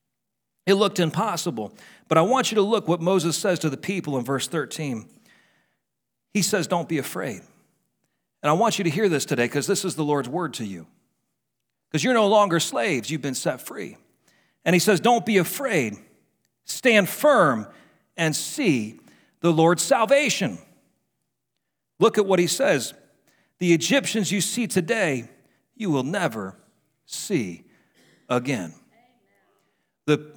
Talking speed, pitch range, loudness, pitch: 150 wpm, 145-205 Hz, -22 LUFS, 175 Hz